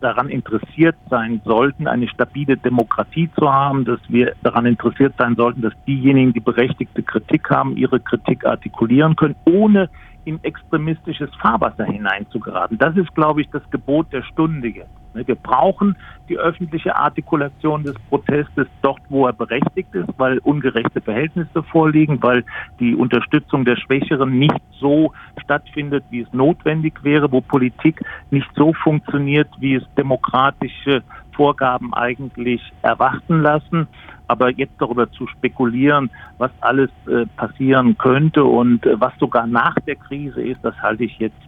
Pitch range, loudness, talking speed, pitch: 120-150 Hz, -17 LUFS, 145 wpm, 135 Hz